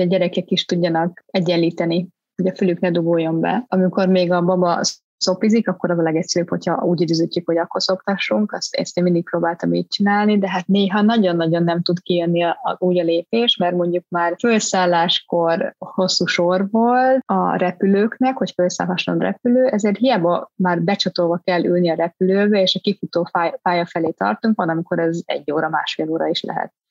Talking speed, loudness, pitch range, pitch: 180 wpm, -18 LUFS, 170-195 Hz, 180 Hz